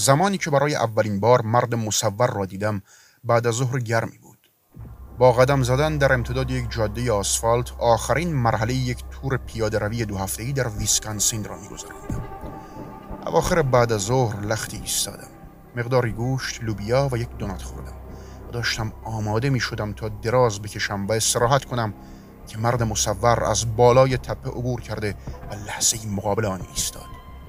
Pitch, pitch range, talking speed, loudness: 115 Hz, 105-125 Hz, 155 wpm, -22 LUFS